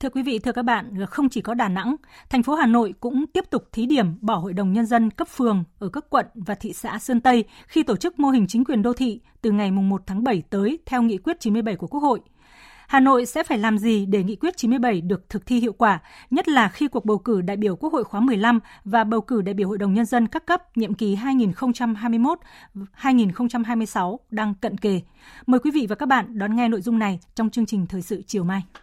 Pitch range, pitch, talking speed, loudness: 205-255 Hz, 230 Hz, 250 wpm, -22 LUFS